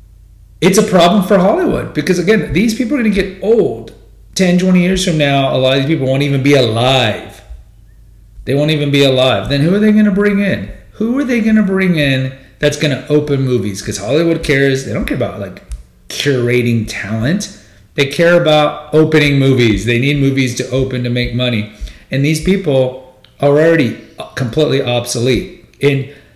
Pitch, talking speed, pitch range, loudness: 140 Hz, 190 wpm, 125-175 Hz, -13 LUFS